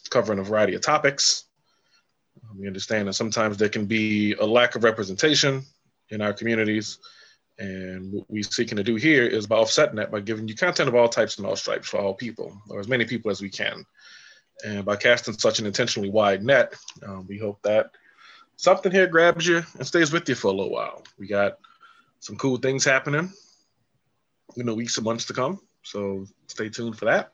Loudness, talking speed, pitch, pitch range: -23 LUFS, 200 wpm, 115 Hz, 105-130 Hz